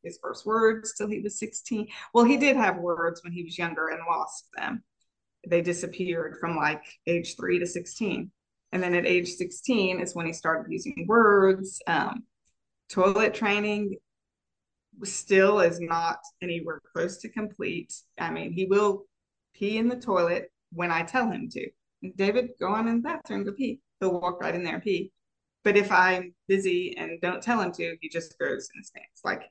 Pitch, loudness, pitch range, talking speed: 190 Hz, -27 LUFS, 175-215 Hz, 185 wpm